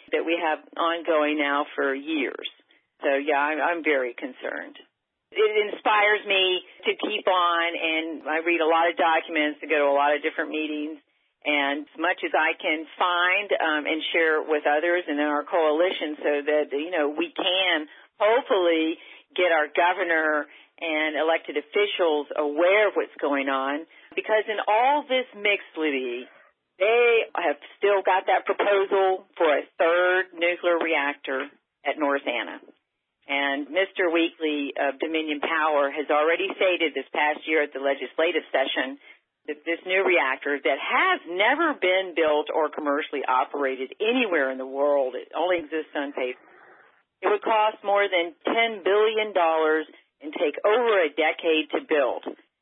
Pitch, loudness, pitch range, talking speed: 160 Hz, -24 LUFS, 150-185 Hz, 160 wpm